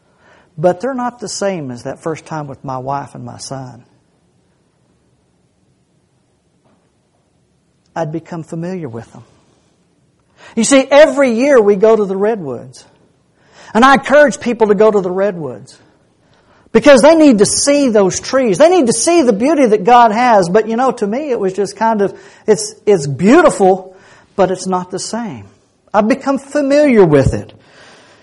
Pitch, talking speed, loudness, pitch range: 200 Hz, 165 wpm, -12 LUFS, 155-245 Hz